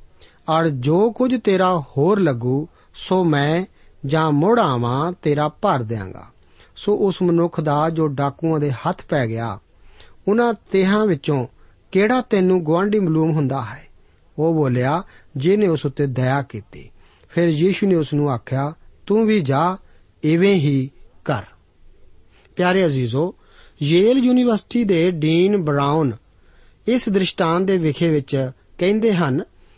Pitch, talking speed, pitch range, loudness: 155 Hz, 135 wpm, 130-185 Hz, -19 LUFS